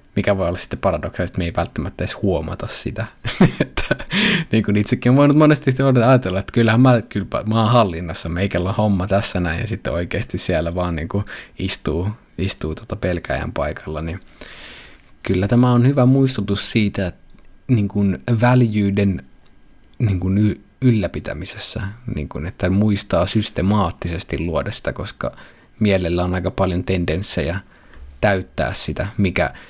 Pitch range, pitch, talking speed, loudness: 90-110 Hz, 100 Hz, 135 wpm, -19 LUFS